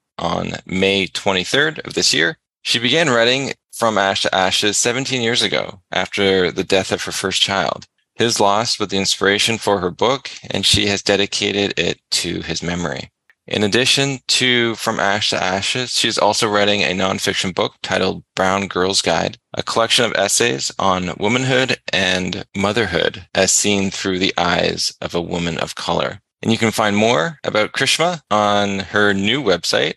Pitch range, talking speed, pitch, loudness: 95-115 Hz, 170 wpm, 100 Hz, -17 LUFS